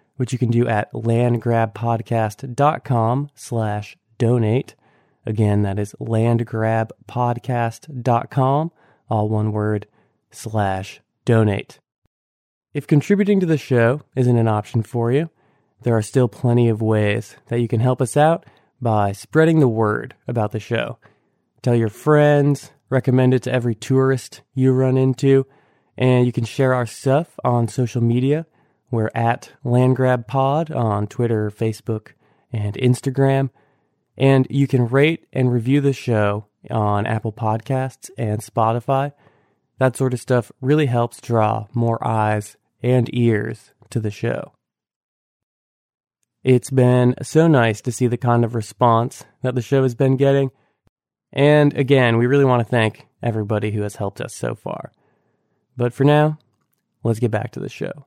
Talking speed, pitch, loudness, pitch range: 145 wpm, 120 Hz, -19 LUFS, 110-135 Hz